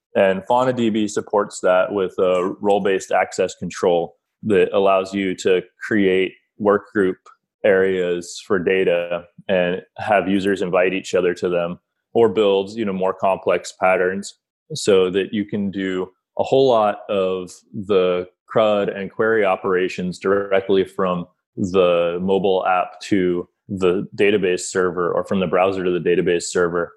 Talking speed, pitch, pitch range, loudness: 140 wpm, 95 Hz, 90-100 Hz, -19 LUFS